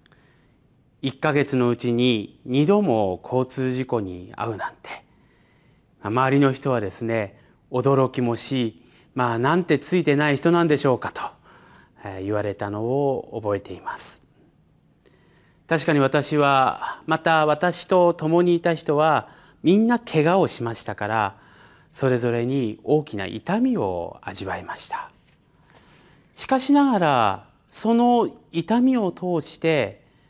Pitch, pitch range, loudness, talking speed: 135 Hz, 120-165 Hz, -22 LUFS, 235 characters per minute